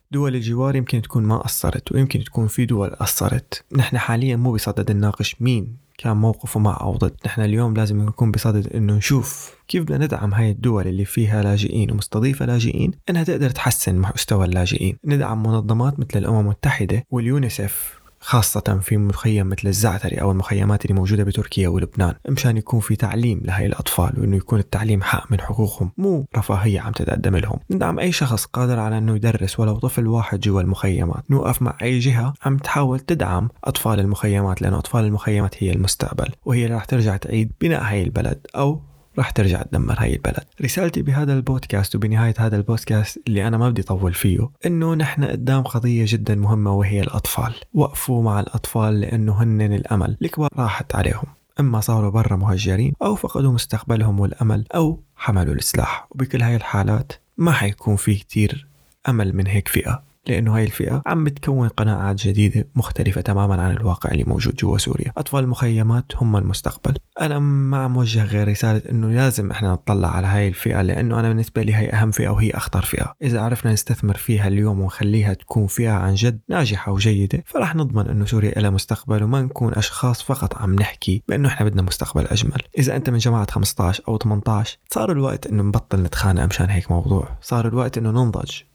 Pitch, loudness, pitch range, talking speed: 110 Hz, -20 LUFS, 100-125 Hz, 175 wpm